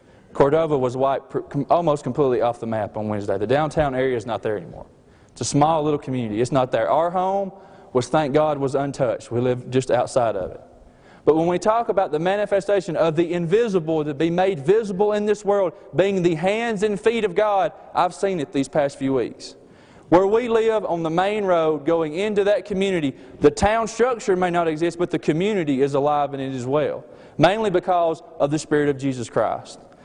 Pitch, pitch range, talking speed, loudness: 165 Hz, 140-195 Hz, 205 wpm, -21 LUFS